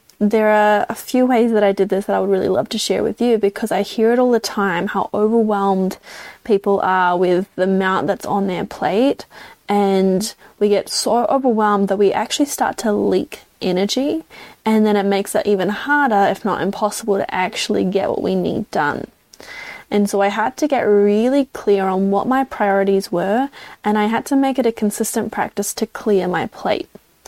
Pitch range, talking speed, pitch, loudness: 195-225 Hz, 200 wpm, 205 Hz, -18 LUFS